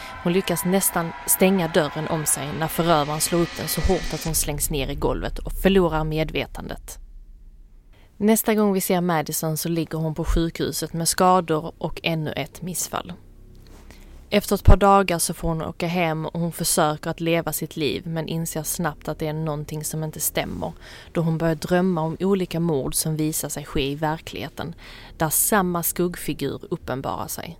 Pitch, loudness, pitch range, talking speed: 160 Hz, -23 LUFS, 150-175 Hz, 180 wpm